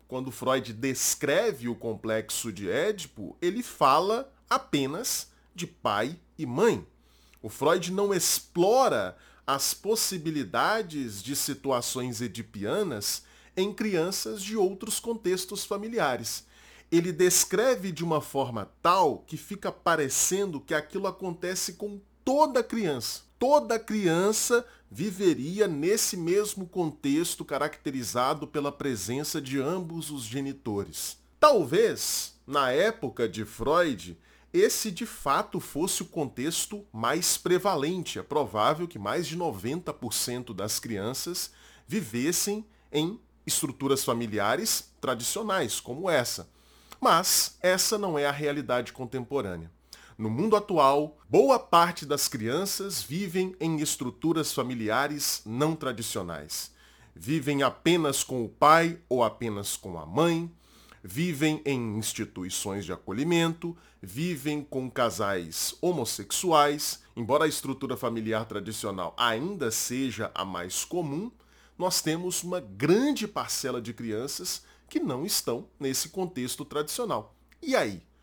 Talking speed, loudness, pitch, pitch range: 115 wpm, -28 LUFS, 150 Hz, 120-185 Hz